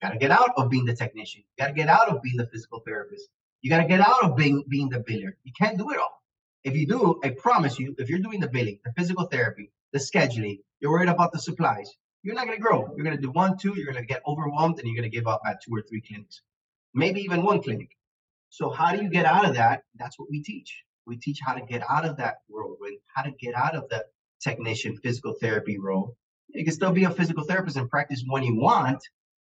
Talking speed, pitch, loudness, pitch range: 250 wpm, 140 Hz, -25 LUFS, 120-175 Hz